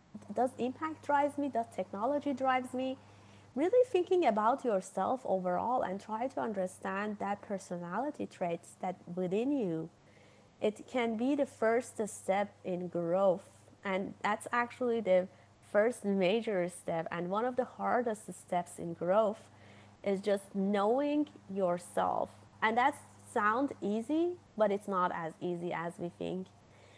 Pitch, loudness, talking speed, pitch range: 200 Hz, -34 LUFS, 140 wpm, 180-245 Hz